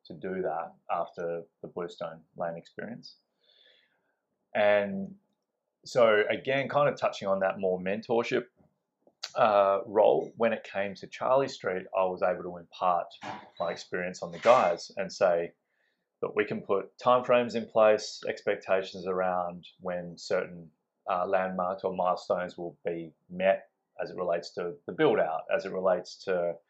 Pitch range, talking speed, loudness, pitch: 90-110 Hz, 155 wpm, -29 LUFS, 95 Hz